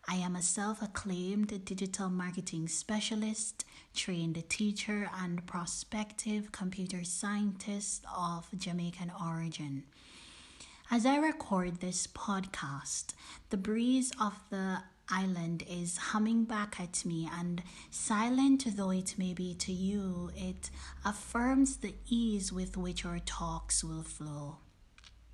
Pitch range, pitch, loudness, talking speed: 175-210 Hz, 185 Hz, -35 LUFS, 120 wpm